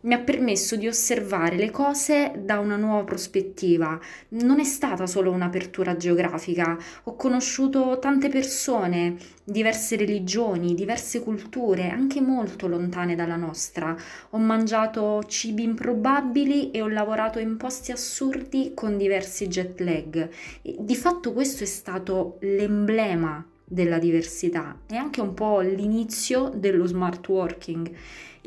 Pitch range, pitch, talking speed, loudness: 180-240 Hz, 210 Hz, 130 wpm, -25 LUFS